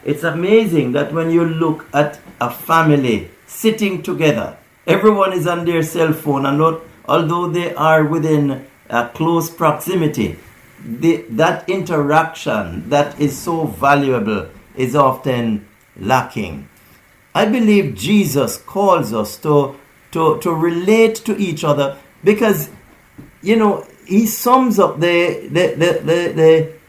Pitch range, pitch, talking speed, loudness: 140-175 Hz, 160 Hz, 135 wpm, -16 LUFS